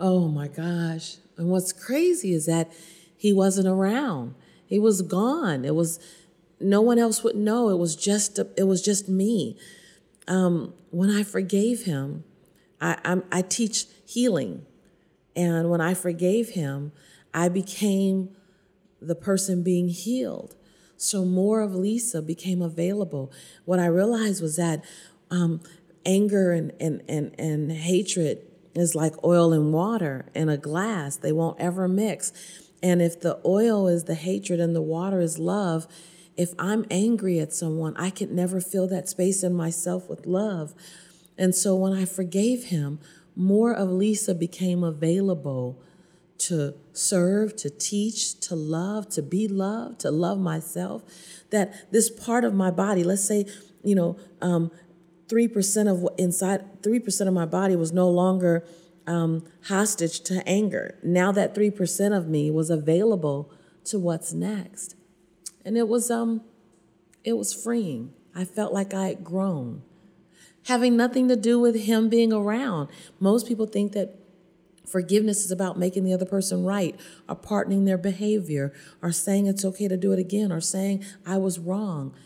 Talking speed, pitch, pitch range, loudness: 160 wpm, 185 Hz, 170-200 Hz, -25 LUFS